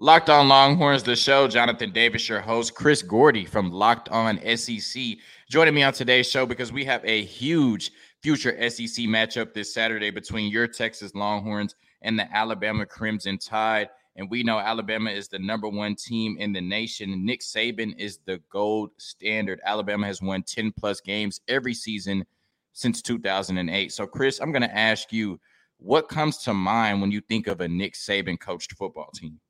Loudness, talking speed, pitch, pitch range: -23 LUFS, 180 wpm, 110 Hz, 105-120 Hz